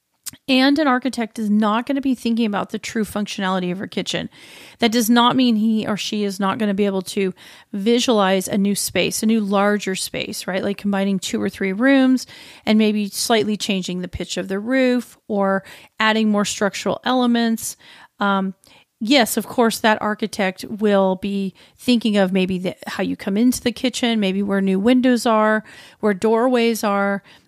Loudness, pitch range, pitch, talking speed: -19 LUFS, 195-235 Hz, 210 Hz, 185 wpm